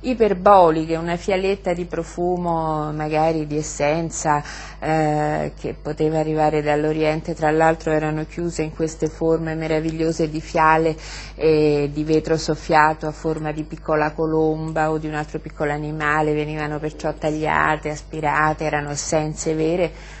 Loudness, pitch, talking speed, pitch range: -21 LUFS, 155 Hz, 135 wpm, 155-160 Hz